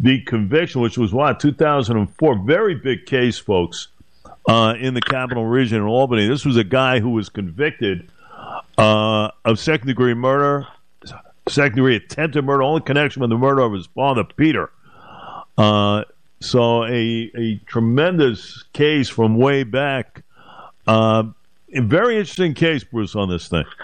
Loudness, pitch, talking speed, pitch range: -18 LUFS, 120 Hz, 150 wpm, 110-140 Hz